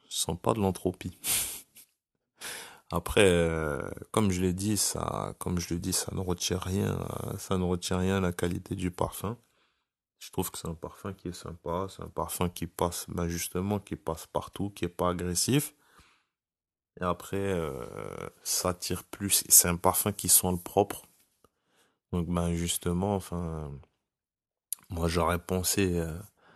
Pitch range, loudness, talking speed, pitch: 85-95 Hz, -29 LUFS, 165 wpm, 90 Hz